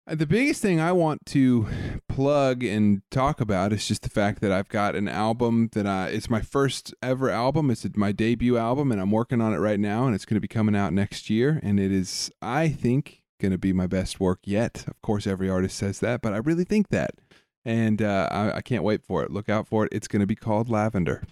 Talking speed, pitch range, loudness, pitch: 240 wpm, 100-125 Hz, -25 LUFS, 110 Hz